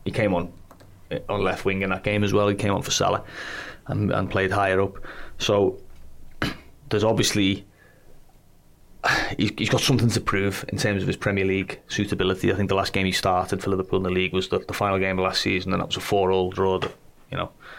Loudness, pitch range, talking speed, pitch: -24 LUFS, 95-105 Hz, 225 wpm, 95 Hz